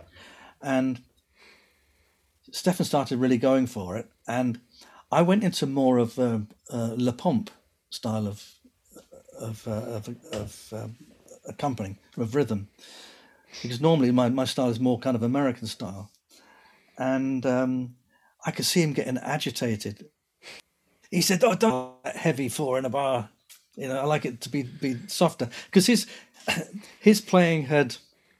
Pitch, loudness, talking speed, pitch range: 130 Hz, -26 LUFS, 150 wpm, 115-150 Hz